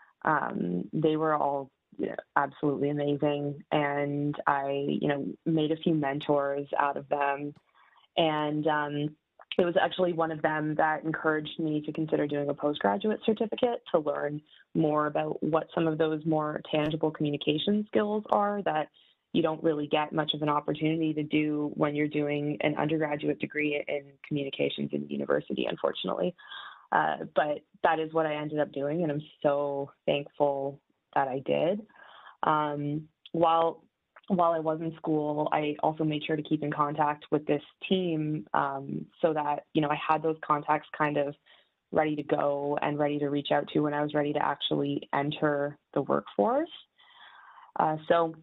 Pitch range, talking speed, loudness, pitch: 145-160 Hz, 170 wpm, -29 LUFS, 150 Hz